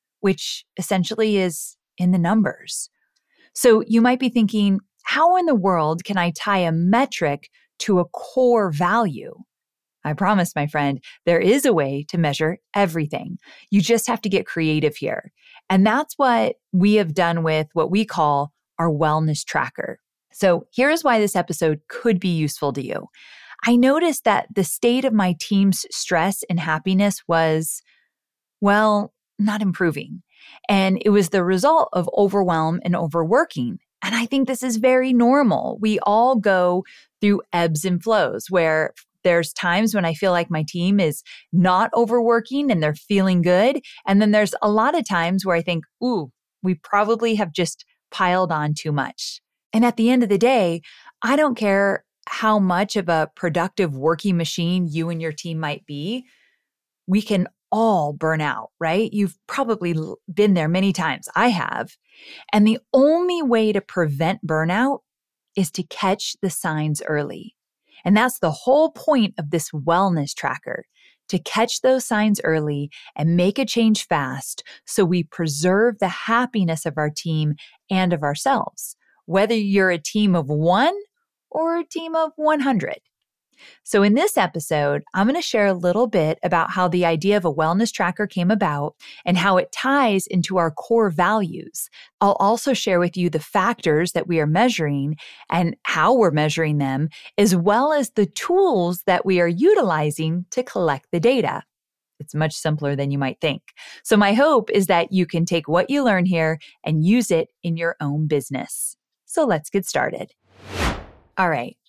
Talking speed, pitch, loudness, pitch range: 170 wpm, 190 Hz, -20 LUFS, 165-220 Hz